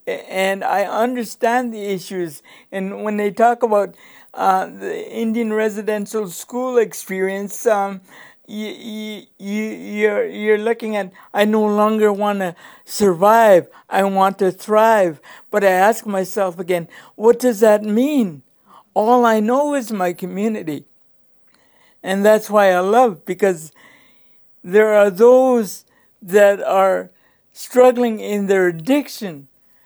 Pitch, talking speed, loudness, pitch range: 210 Hz, 130 wpm, -17 LUFS, 195-230 Hz